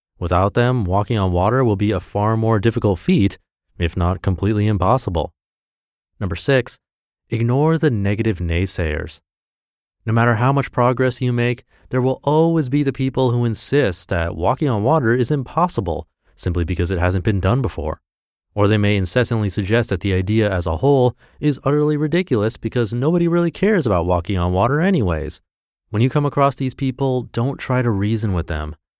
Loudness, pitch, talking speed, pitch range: -19 LUFS, 110 Hz, 175 wpm, 95-130 Hz